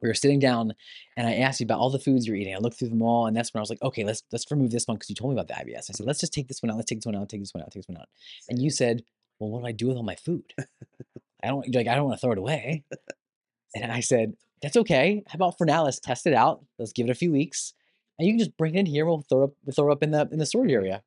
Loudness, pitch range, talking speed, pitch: -26 LUFS, 115-145 Hz, 340 wpm, 125 Hz